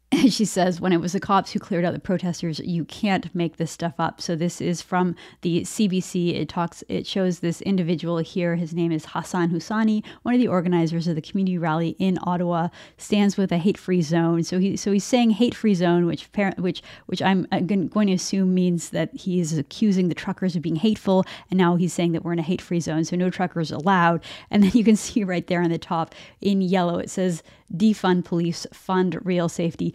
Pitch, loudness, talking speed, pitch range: 180 Hz, -23 LUFS, 220 wpm, 170-195 Hz